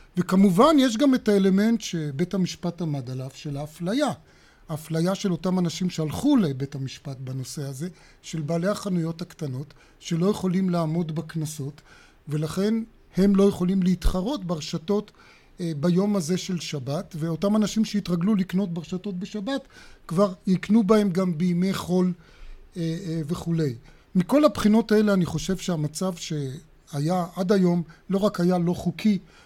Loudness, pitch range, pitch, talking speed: -25 LUFS, 165-200 Hz, 180 Hz, 140 wpm